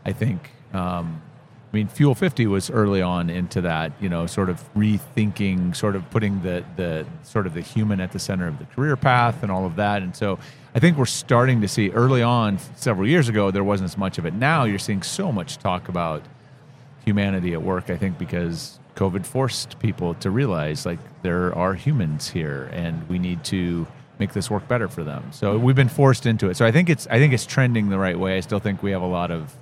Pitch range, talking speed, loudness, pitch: 90-125 Hz, 230 wpm, -22 LUFS, 100 Hz